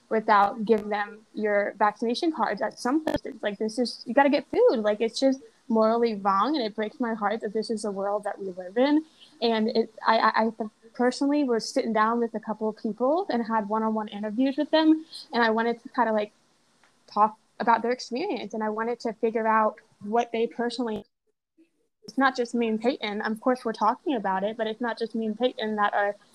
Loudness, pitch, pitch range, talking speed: -26 LUFS, 225 Hz, 215-250 Hz, 225 wpm